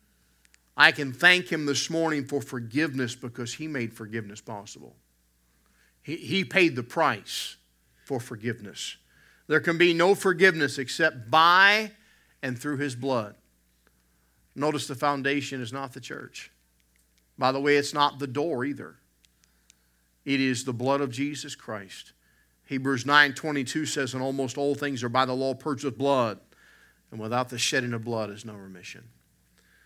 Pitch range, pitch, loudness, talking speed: 100-145 Hz, 130 Hz, -25 LUFS, 155 wpm